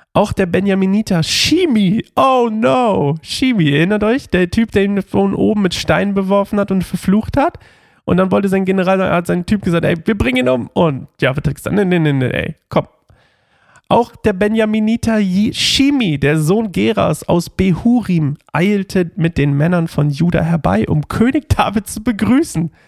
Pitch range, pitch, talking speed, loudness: 165-215 Hz, 190 Hz, 170 wpm, -15 LUFS